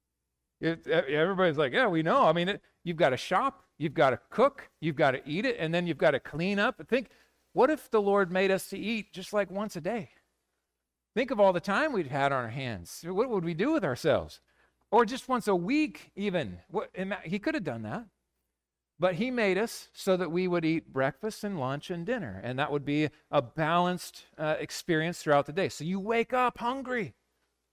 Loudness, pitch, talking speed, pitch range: -29 LUFS, 175 Hz, 220 wpm, 145-205 Hz